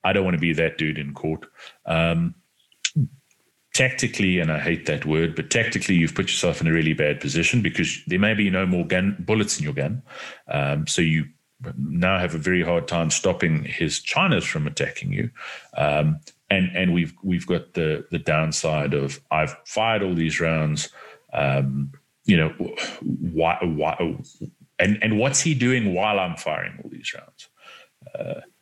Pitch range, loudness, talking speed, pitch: 80-100 Hz, -23 LUFS, 175 wpm, 85 Hz